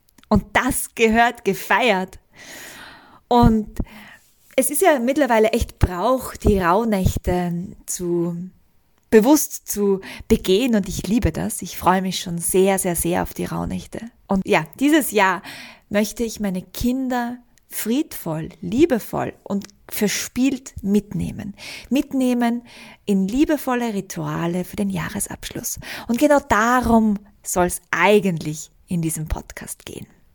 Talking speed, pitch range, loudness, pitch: 120 wpm, 185-250 Hz, -20 LUFS, 210 Hz